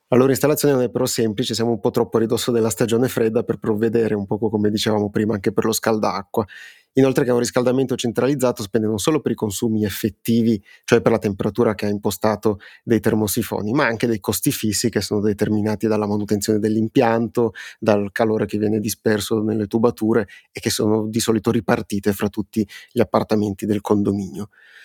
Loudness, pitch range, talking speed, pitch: -20 LUFS, 105-120 Hz, 190 wpm, 110 Hz